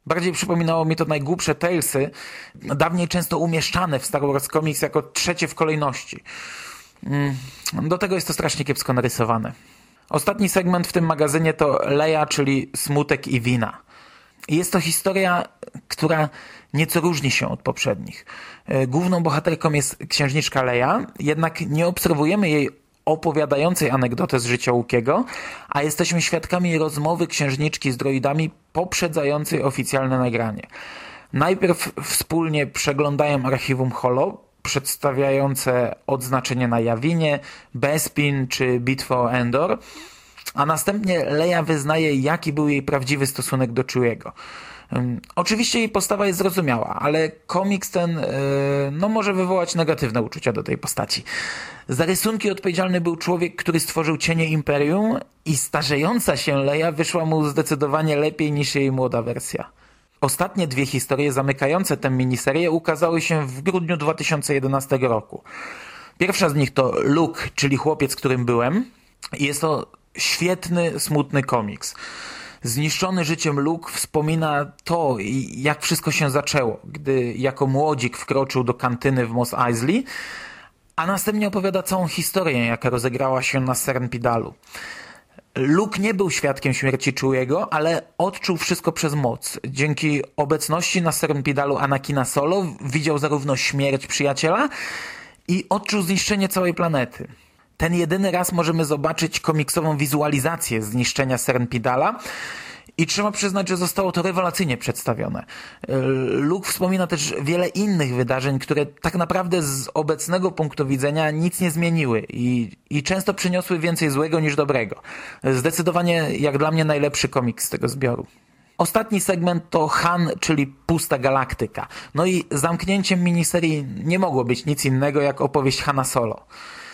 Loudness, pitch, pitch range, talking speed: -21 LUFS, 155 Hz, 135-175 Hz, 135 wpm